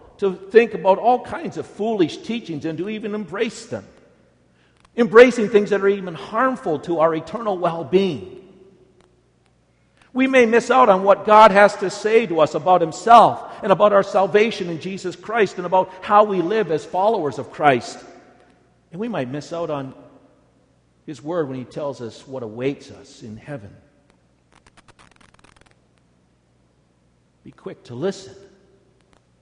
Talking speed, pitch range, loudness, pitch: 155 wpm, 135-210 Hz, -18 LUFS, 185 Hz